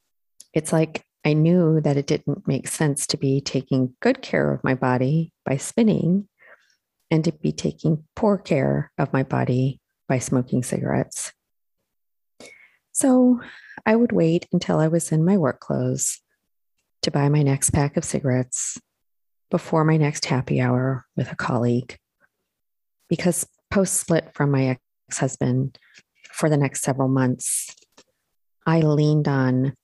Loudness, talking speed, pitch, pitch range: -22 LUFS, 145 wpm, 145 Hz, 130-170 Hz